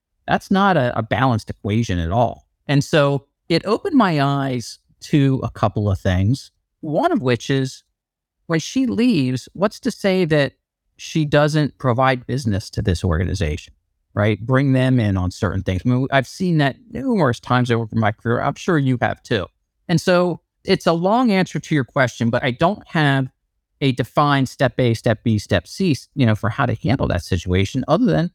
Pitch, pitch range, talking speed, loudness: 130 Hz, 110-155 Hz, 190 wpm, -19 LUFS